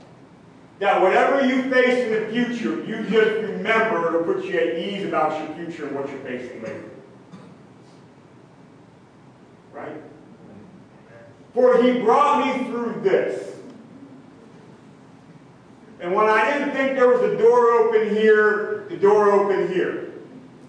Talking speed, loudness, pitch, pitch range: 130 wpm, -20 LUFS, 220 Hz, 195-260 Hz